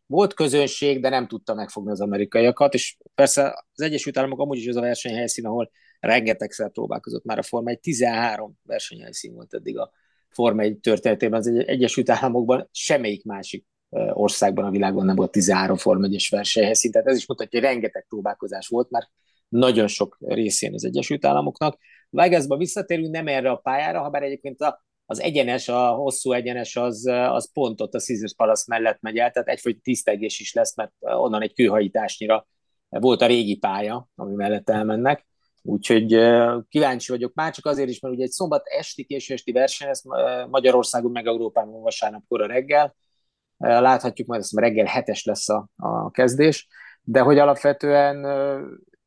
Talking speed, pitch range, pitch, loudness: 170 wpm, 115-140 Hz, 125 Hz, -22 LUFS